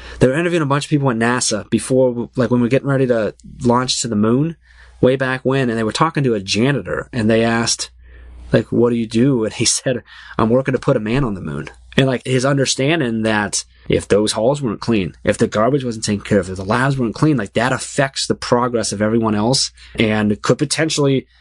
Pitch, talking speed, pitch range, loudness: 120 Hz, 235 wpm, 110-135 Hz, -17 LUFS